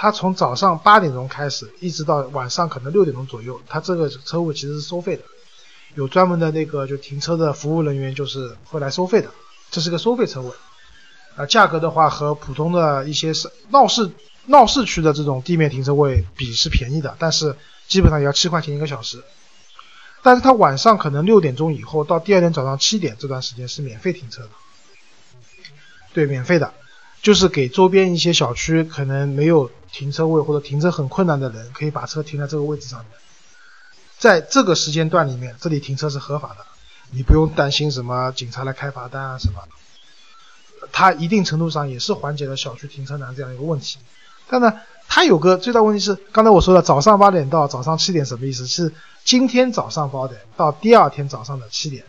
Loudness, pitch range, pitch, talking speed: -18 LUFS, 135-180 Hz, 150 Hz, 315 characters per minute